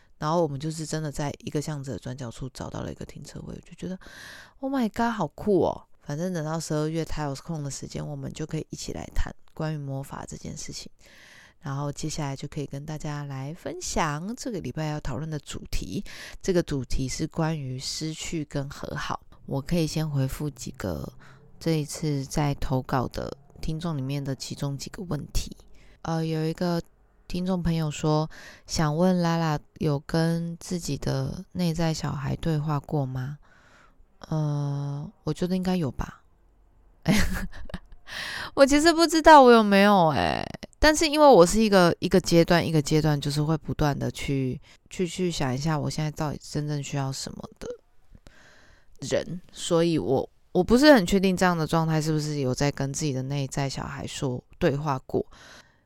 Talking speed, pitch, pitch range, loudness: 270 characters per minute, 155 Hz, 140-170 Hz, -26 LUFS